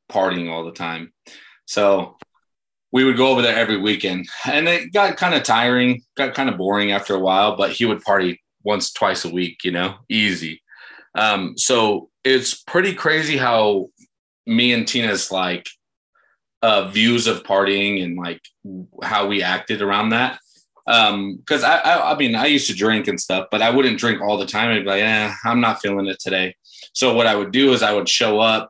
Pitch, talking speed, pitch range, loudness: 105 Hz, 200 wpm, 95-120 Hz, -18 LUFS